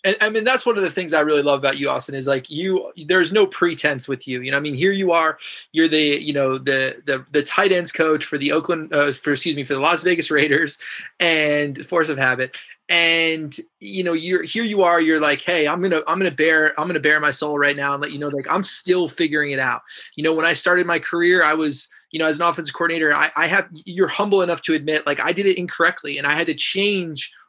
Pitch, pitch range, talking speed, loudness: 160 Hz, 145-180 Hz, 260 wpm, -19 LUFS